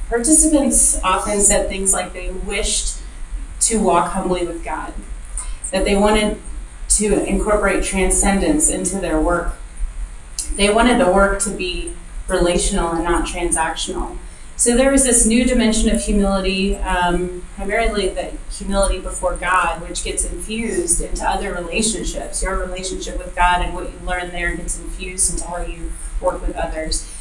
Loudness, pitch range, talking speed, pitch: -18 LUFS, 175-205 Hz, 150 wpm, 185 Hz